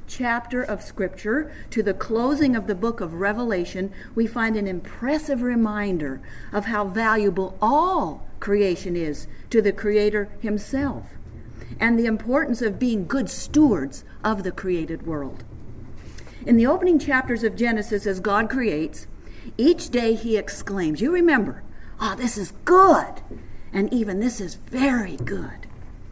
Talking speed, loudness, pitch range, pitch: 140 wpm, -23 LUFS, 190-245 Hz, 215 Hz